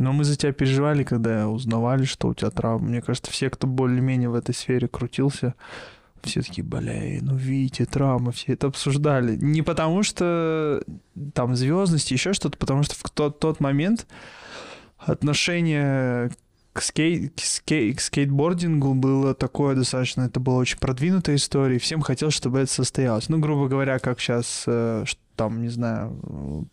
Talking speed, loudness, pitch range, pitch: 165 wpm, -23 LUFS, 125-150 Hz, 135 Hz